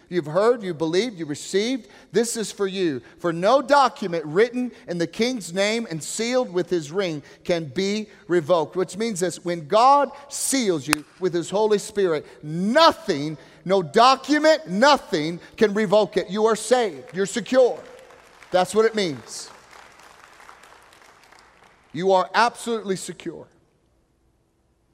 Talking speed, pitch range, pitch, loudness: 135 wpm, 175-230 Hz, 195 Hz, -22 LUFS